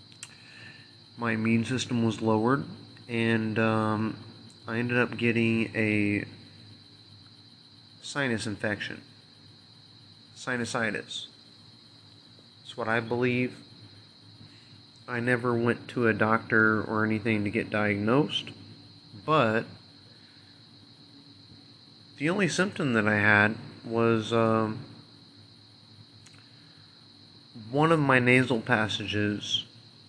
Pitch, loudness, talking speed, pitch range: 115 Hz, -27 LUFS, 90 wpm, 110-125 Hz